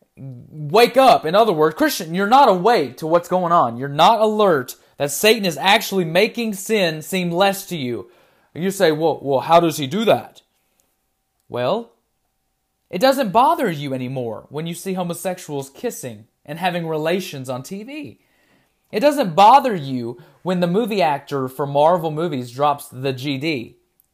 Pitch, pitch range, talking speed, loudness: 175 Hz, 140-205 Hz, 160 wpm, -18 LUFS